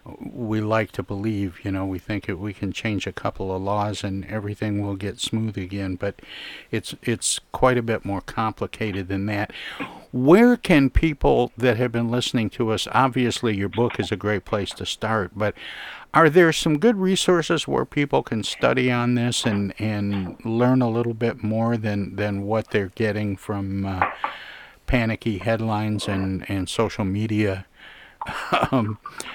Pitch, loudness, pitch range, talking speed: 110 Hz, -23 LUFS, 100-120 Hz, 170 wpm